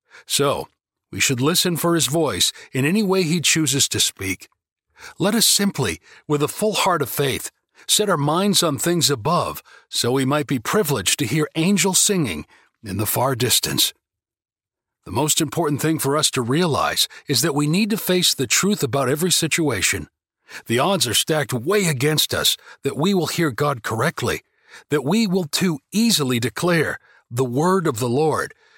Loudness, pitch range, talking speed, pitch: -19 LUFS, 135-180 Hz, 175 wpm, 155 Hz